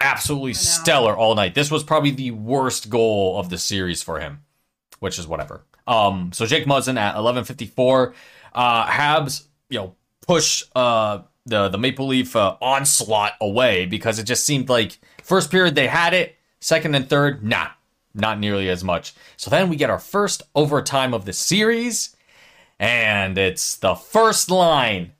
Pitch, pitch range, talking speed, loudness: 125 Hz, 105-145 Hz, 170 wpm, -19 LUFS